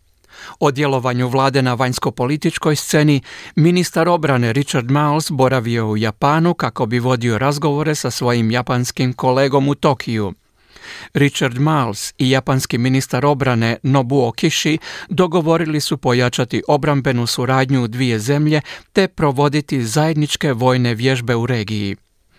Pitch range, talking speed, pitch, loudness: 125-150 Hz, 125 wpm, 135 Hz, -17 LUFS